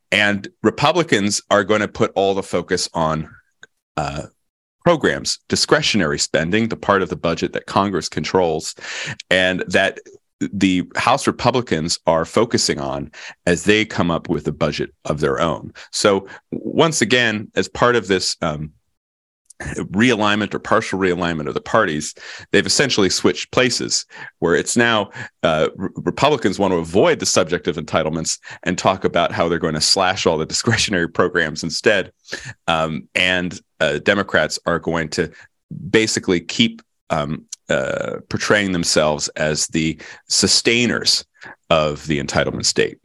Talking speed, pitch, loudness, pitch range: 145 wpm, 95 Hz, -18 LUFS, 85-110 Hz